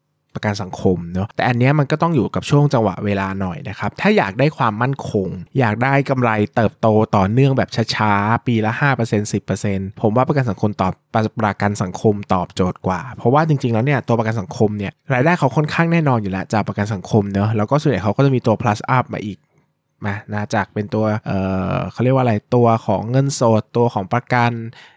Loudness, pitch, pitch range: -18 LUFS, 110 Hz, 105-130 Hz